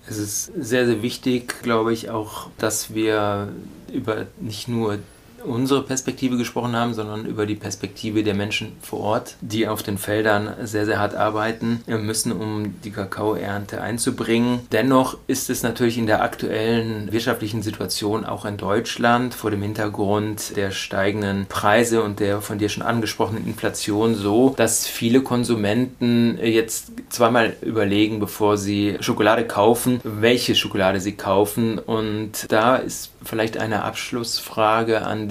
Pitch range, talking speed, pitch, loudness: 105-115 Hz, 145 wpm, 110 Hz, -22 LUFS